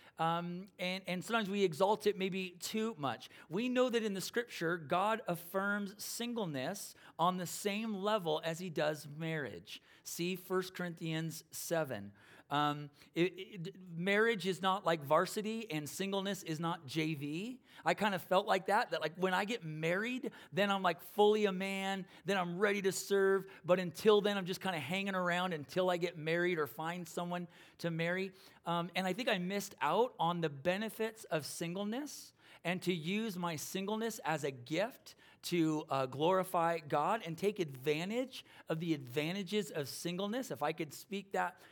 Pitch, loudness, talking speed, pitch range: 180 Hz, -36 LUFS, 175 wpm, 165-200 Hz